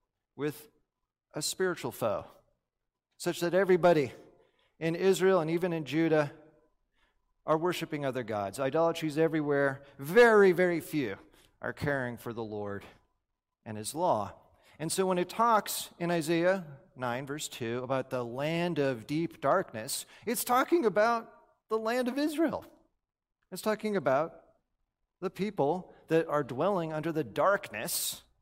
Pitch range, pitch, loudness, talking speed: 140-190 Hz, 165 Hz, -30 LUFS, 135 wpm